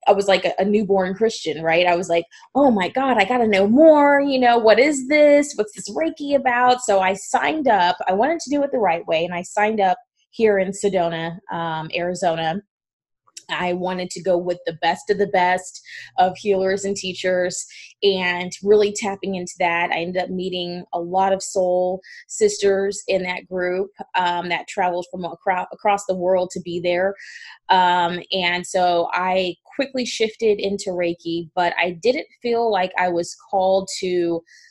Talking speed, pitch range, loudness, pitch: 185 wpm, 180-210 Hz, -20 LUFS, 185 Hz